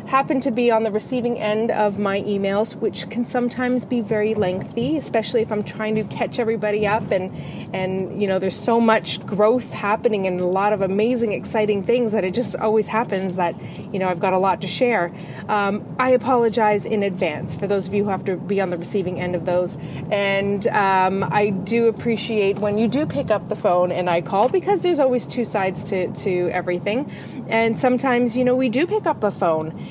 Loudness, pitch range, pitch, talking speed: -21 LUFS, 190-230 Hz, 210 Hz, 215 wpm